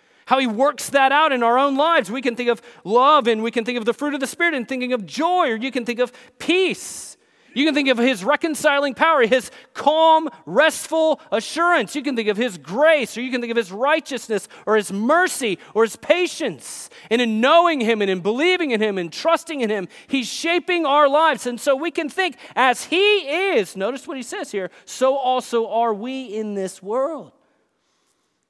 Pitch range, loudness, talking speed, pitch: 235-310 Hz, -19 LUFS, 215 wpm, 265 Hz